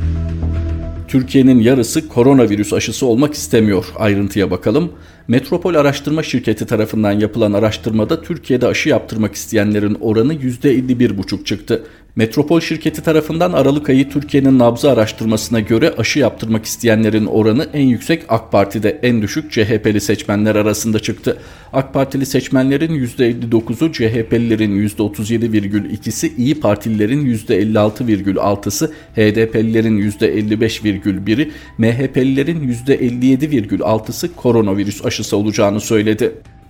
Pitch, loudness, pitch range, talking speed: 115 Hz, -15 LUFS, 105-135 Hz, 100 wpm